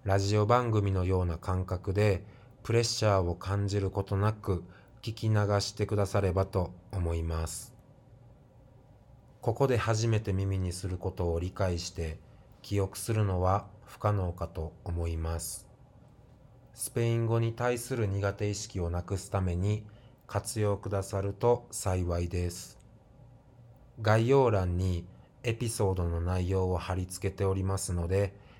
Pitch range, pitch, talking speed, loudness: 95-115 Hz, 100 Hz, 270 characters per minute, -31 LUFS